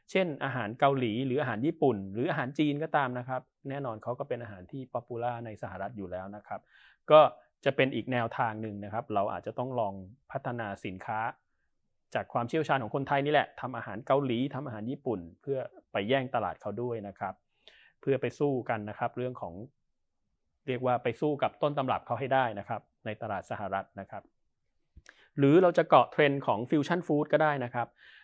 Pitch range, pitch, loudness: 110-140 Hz, 125 Hz, -30 LUFS